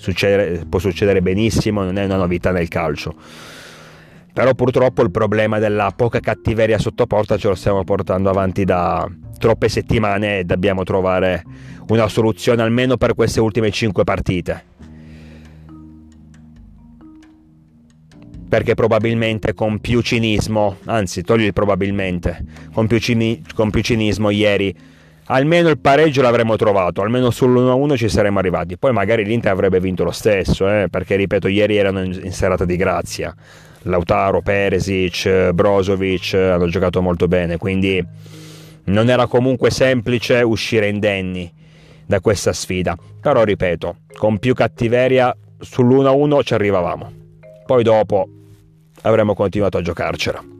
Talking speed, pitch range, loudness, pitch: 130 wpm, 90-115 Hz, -17 LUFS, 105 Hz